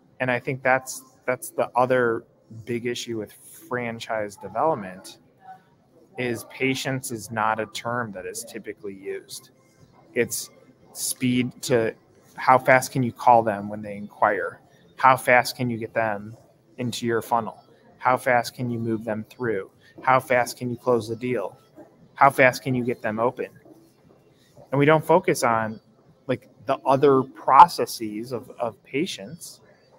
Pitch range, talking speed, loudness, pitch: 115-130 Hz, 150 wpm, -23 LUFS, 125 Hz